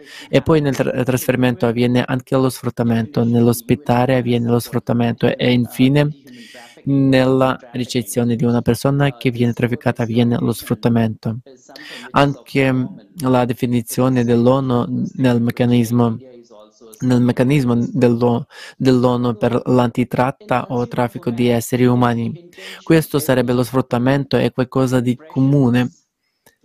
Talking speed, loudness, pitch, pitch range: 115 wpm, -17 LUFS, 125 Hz, 120-130 Hz